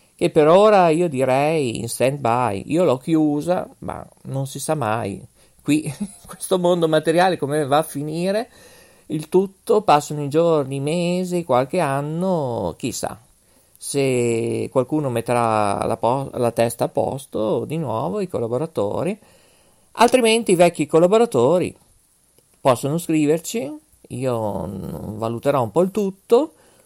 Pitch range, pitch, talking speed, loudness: 125-175 Hz, 150 Hz, 135 wpm, -20 LUFS